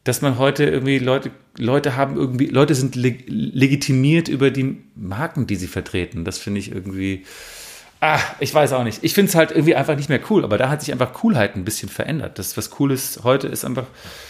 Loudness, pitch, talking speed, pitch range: -19 LUFS, 135 Hz, 220 wpm, 110-145 Hz